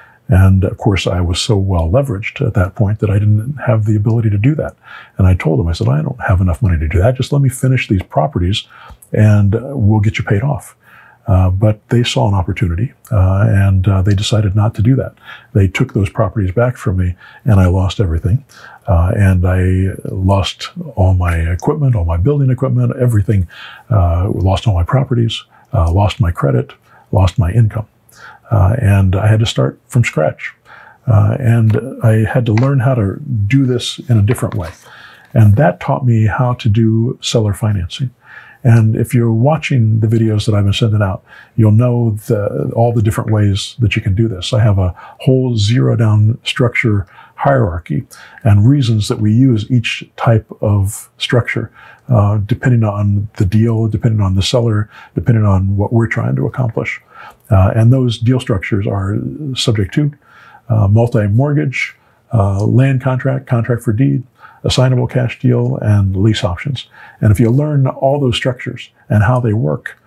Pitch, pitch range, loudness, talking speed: 110 Hz, 100-125 Hz, -14 LUFS, 185 wpm